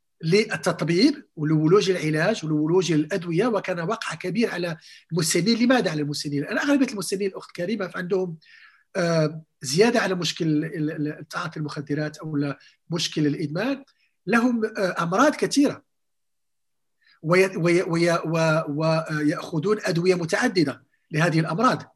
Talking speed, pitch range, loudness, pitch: 95 wpm, 155-200 Hz, -23 LUFS, 175 Hz